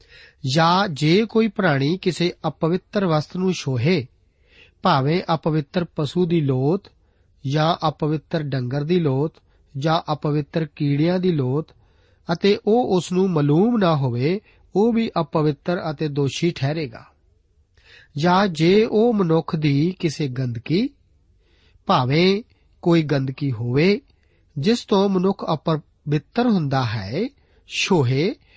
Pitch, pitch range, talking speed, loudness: 160 Hz, 140-185 Hz, 115 wpm, -21 LUFS